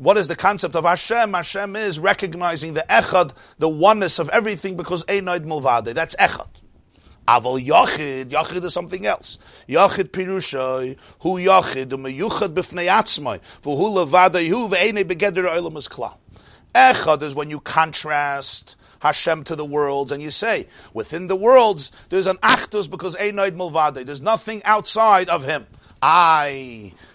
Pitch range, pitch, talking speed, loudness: 145-190 Hz, 170 Hz, 145 wpm, -19 LUFS